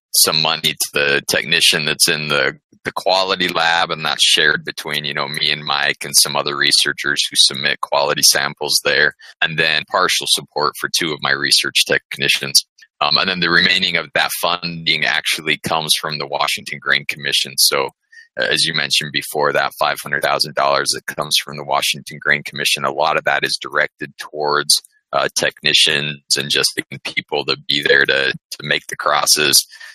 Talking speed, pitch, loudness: 185 wpm, 85 Hz, -15 LUFS